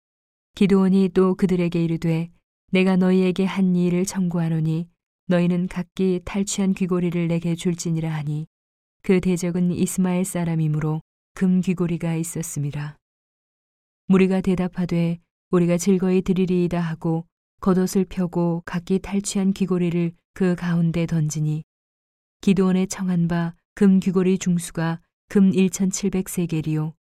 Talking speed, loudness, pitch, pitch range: 285 characters per minute, -22 LUFS, 180 Hz, 170-190 Hz